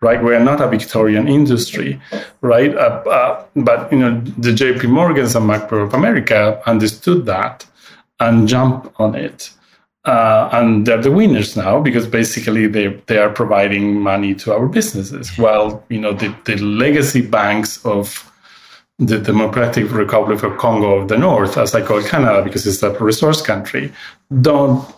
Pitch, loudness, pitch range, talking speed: 110 Hz, -14 LUFS, 105-125 Hz, 160 wpm